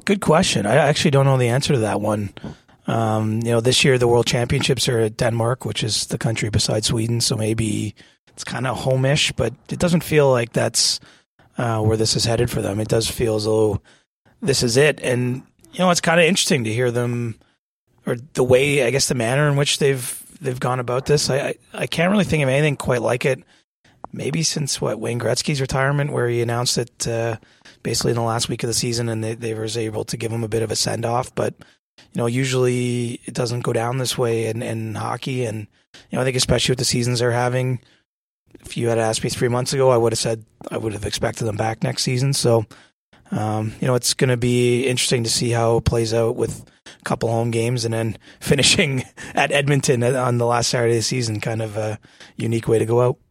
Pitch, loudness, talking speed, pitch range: 120 Hz, -20 LUFS, 230 wpm, 115-135 Hz